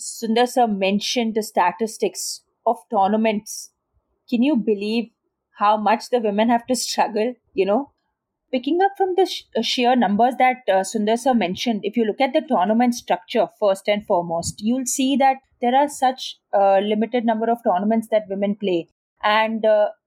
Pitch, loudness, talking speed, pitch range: 225 Hz, -20 LUFS, 175 wpm, 210-250 Hz